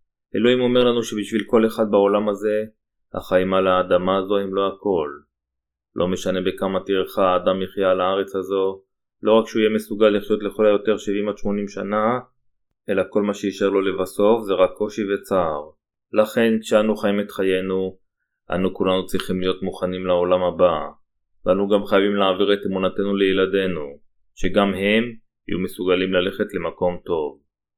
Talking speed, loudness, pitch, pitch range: 155 wpm, -21 LUFS, 100 Hz, 95-105 Hz